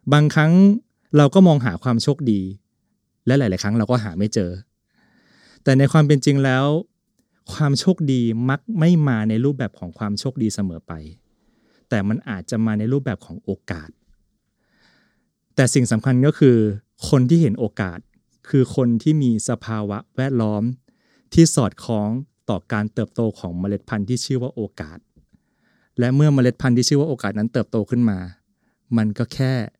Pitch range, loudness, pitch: 110-140 Hz, -19 LUFS, 125 Hz